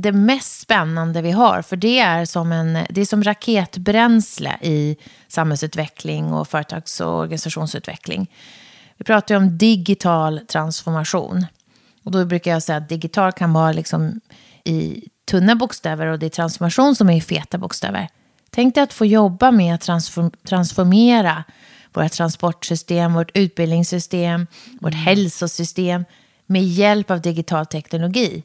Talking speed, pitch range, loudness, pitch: 140 wpm, 160-200 Hz, -18 LUFS, 175 Hz